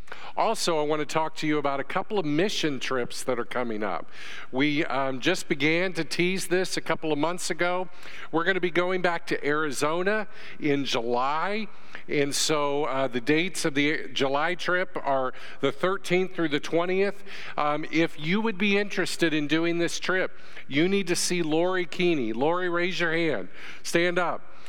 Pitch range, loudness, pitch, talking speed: 150-180 Hz, -26 LUFS, 165 Hz, 185 wpm